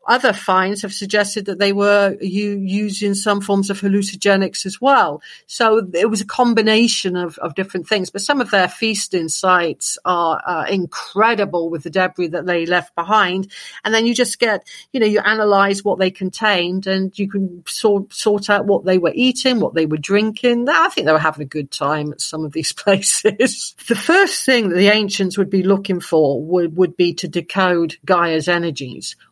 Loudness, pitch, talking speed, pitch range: -17 LUFS, 195 Hz, 195 wpm, 180-210 Hz